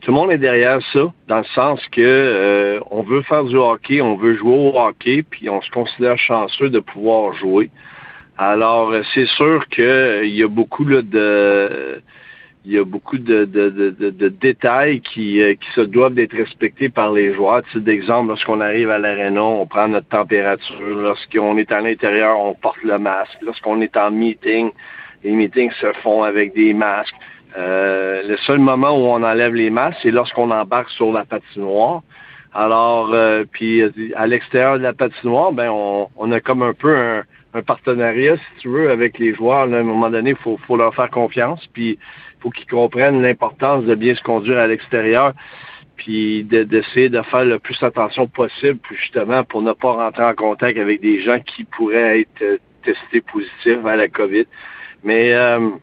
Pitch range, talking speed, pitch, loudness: 105-125 Hz, 190 wpm, 115 Hz, -16 LUFS